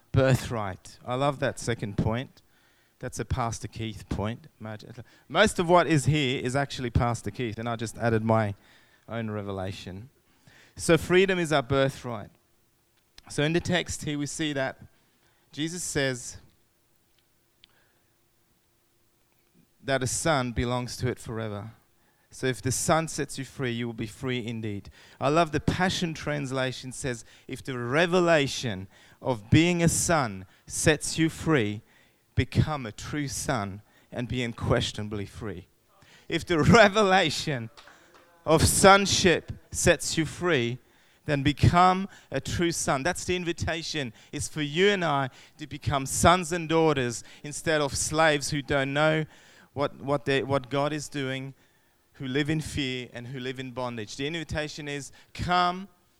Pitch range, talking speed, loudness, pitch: 115-150 Hz, 145 wpm, -26 LUFS, 130 Hz